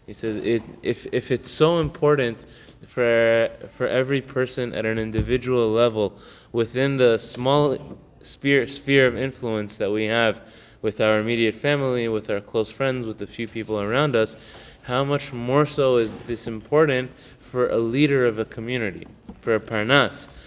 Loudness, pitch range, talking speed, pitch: -22 LUFS, 110-130 Hz, 150 wpm, 120 Hz